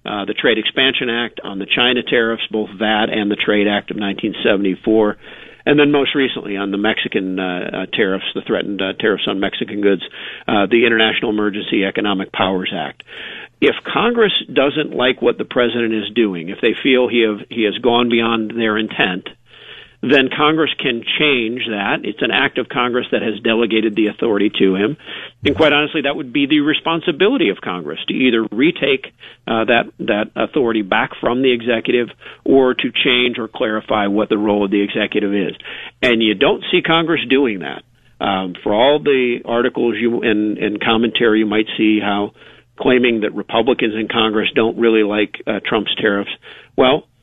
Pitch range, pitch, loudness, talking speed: 105-125 Hz, 115 Hz, -16 LUFS, 180 wpm